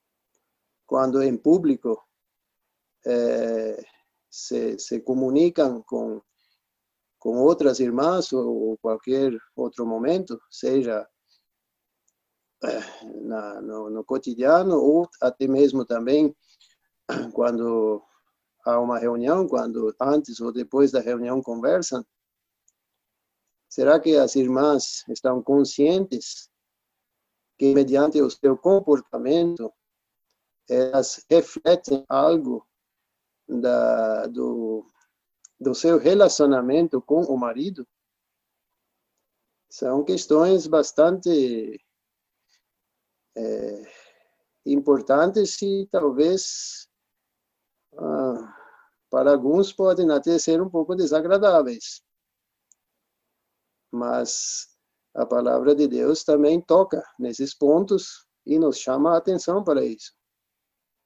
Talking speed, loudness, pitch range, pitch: 85 wpm, -22 LUFS, 120-165 Hz, 140 Hz